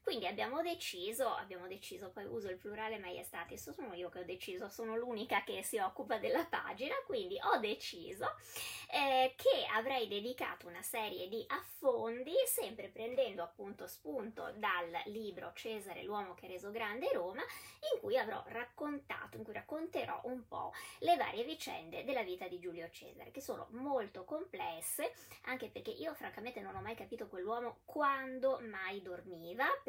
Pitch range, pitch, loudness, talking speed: 200-330 Hz, 240 Hz, -40 LUFS, 155 wpm